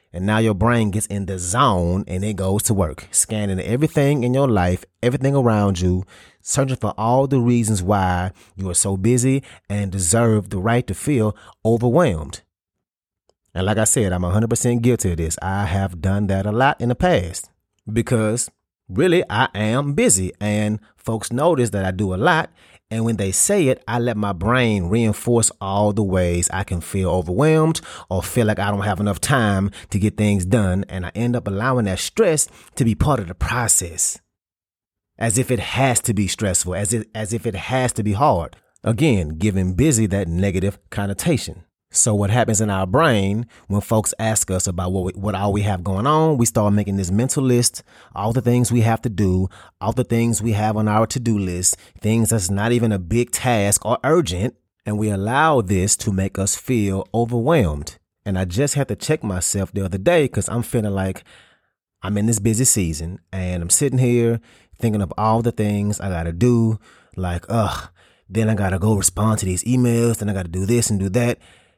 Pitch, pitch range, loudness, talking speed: 105 Hz, 95-120 Hz, -19 LUFS, 205 wpm